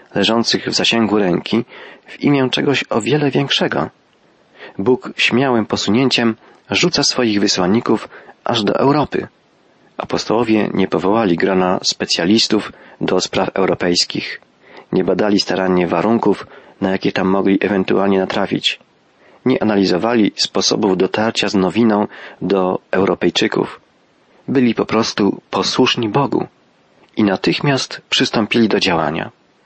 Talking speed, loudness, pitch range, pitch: 110 wpm, -16 LUFS, 95-115 Hz, 105 Hz